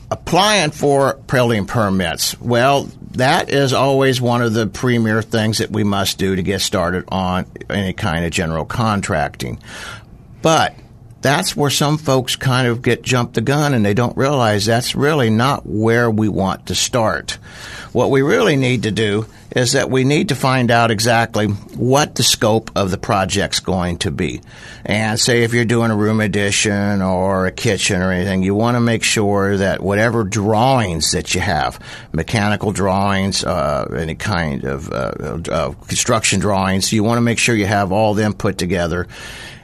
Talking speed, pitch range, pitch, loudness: 175 wpm, 100-120 Hz, 110 Hz, -16 LUFS